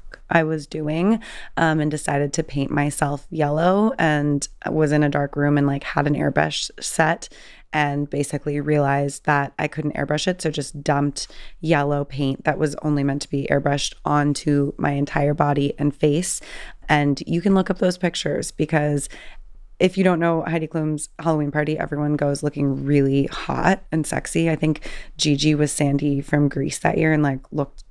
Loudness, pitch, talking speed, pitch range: -21 LUFS, 150 Hz, 180 wpm, 145-160 Hz